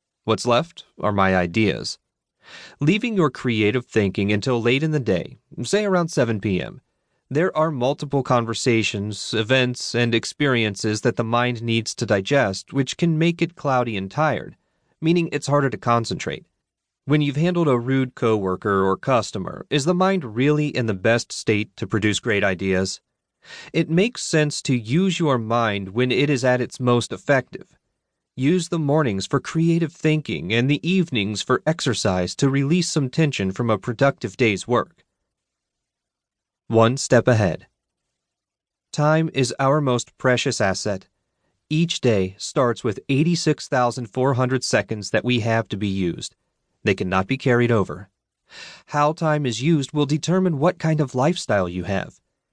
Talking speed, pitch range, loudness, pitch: 155 wpm, 110-150 Hz, -21 LUFS, 125 Hz